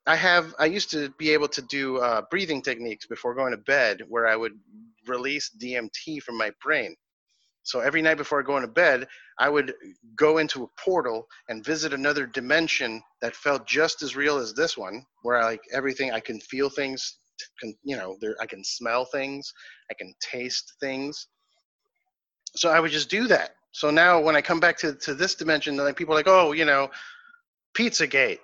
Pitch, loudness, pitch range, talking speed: 145 Hz, -24 LUFS, 130-165 Hz, 195 wpm